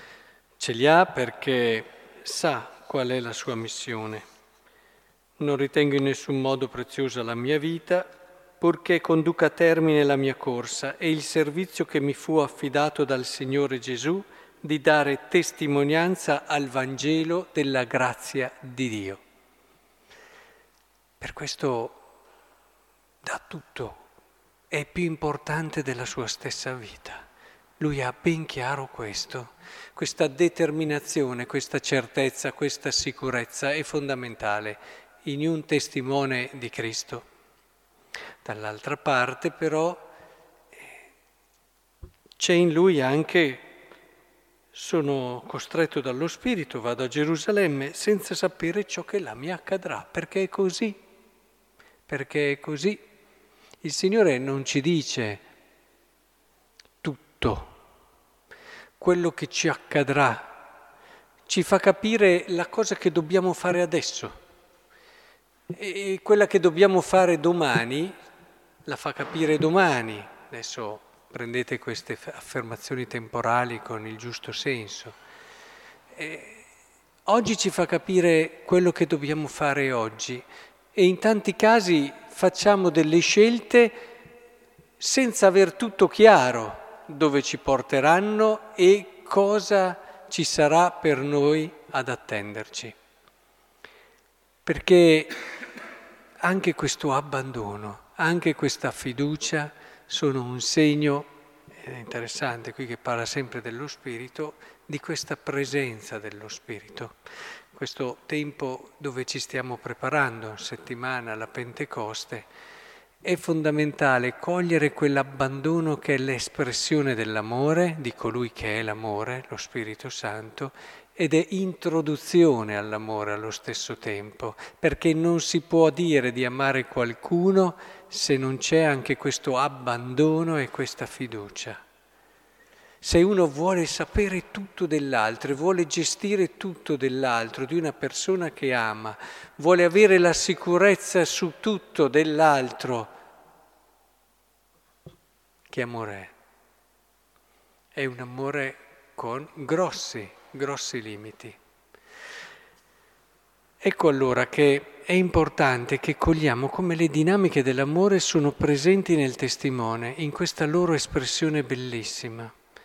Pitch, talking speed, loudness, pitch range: 150 Hz, 110 wpm, -25 LUFS, 130-175 Hz